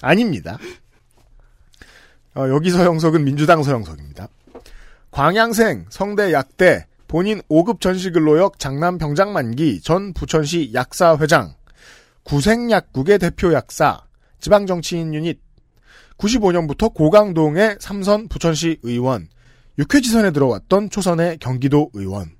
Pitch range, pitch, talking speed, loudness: 140-190 Hz, 165 Hz, 250 characters per minute, -17 LUFS